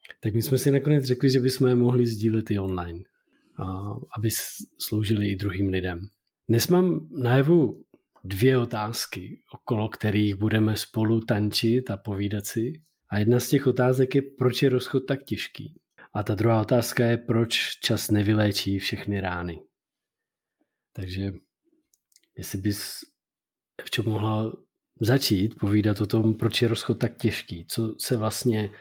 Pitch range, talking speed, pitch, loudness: 105-125 Hz, 150 wpm, 110 Hz, -25 LUFS